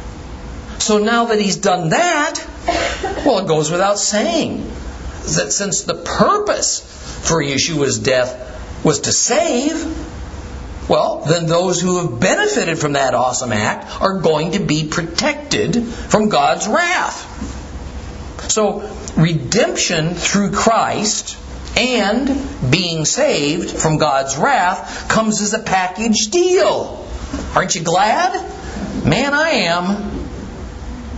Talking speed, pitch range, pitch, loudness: 115 wpm, 145-225 Hz, 180 Hz, -16 LUFS